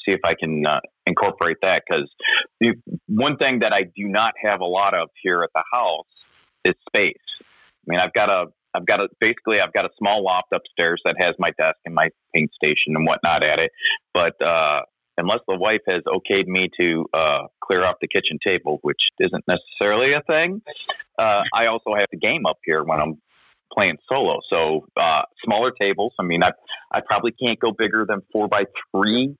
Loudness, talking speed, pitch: -20 LUFS, 205 wpm, 115 Hz